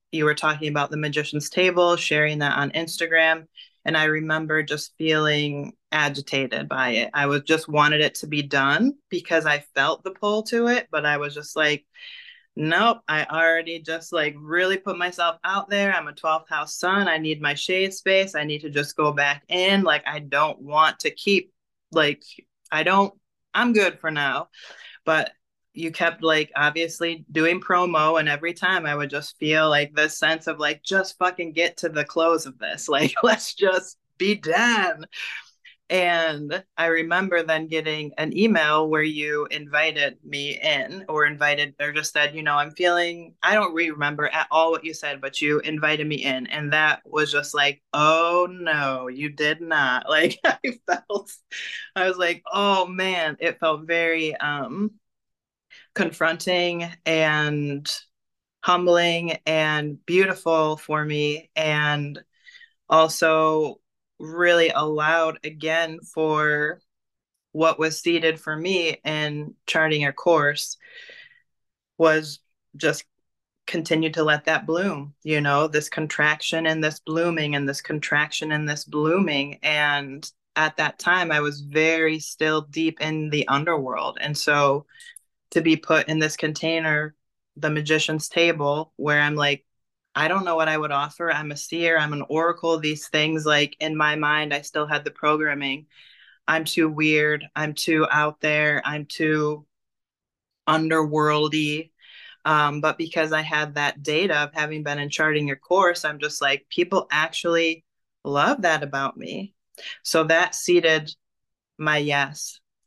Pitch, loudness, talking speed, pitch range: 155 Hz, -22 LUFS, 160 wpm, 150-170 Hz